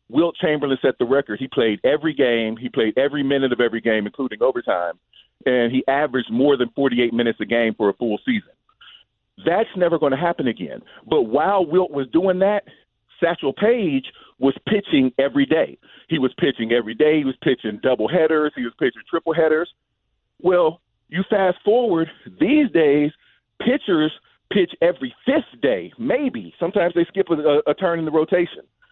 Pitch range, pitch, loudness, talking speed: 130-185 Hz, 155 Hz, -20 LUFS, 175 wpm